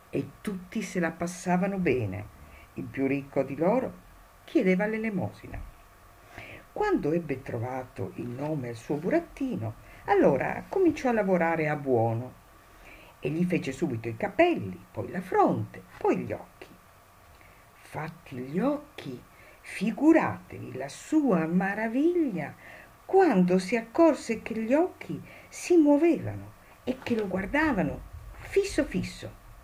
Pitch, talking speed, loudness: 180 Hz, 120 wpm, -28 LUFS